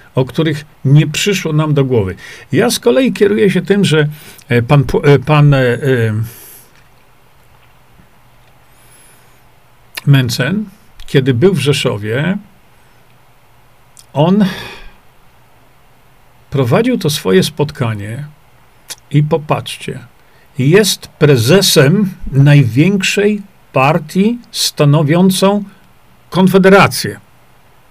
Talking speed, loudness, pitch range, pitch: 75 wpm, -12 LUFS, 130-190 Hz, 150 Hz